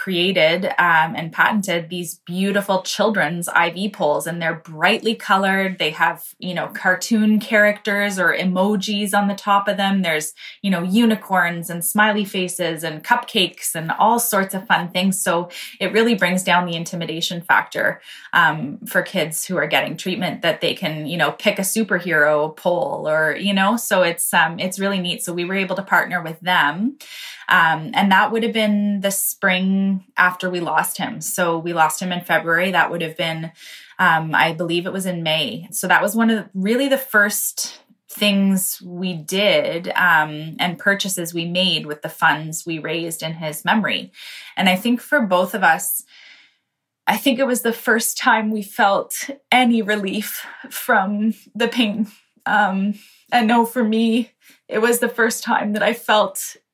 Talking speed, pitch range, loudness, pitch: 180 wpm, 175-215 Hz, -19 LUFS, 195 Hz